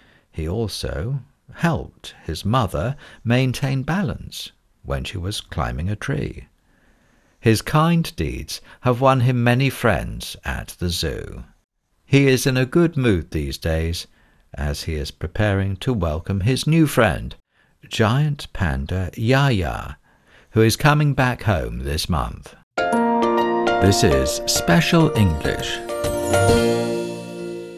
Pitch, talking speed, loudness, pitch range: 115 Hz, 120 wpm, -21 LUFS, 85-130 Hz